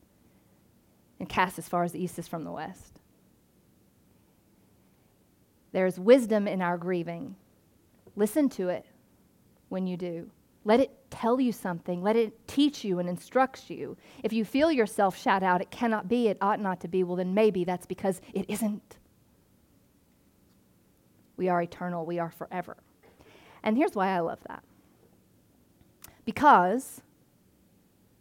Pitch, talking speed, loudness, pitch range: 195 Hz, 145 wpm, -28 LUFS, 180-225 Hz